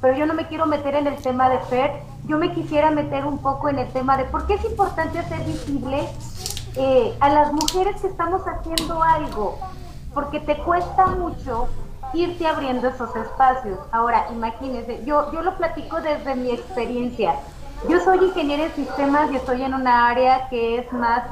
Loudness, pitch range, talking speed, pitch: -21 LUFS, 255-325 Hz, 185 wpm, 290 Hz